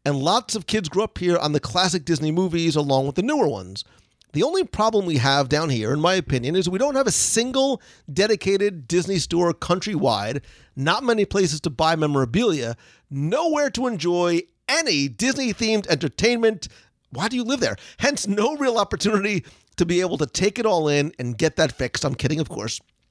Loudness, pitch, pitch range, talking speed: -22 LUFS, 175 Hz, 150-210 Hz, 195 wpm